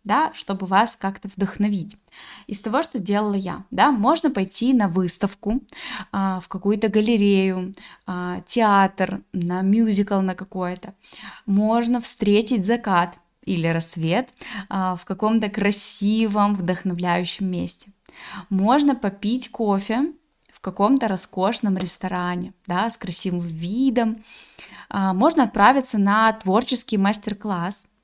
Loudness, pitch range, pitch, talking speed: -21 LUFS, 190-225 Hz, 205 Hz, 115 wpm